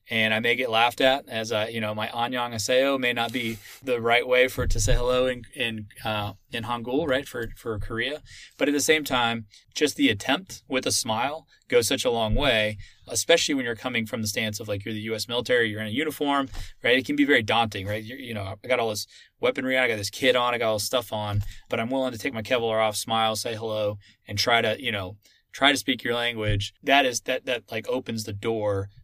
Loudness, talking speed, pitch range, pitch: -25 LUFS, 250 wpm, 110-130 Hz, 115 Hz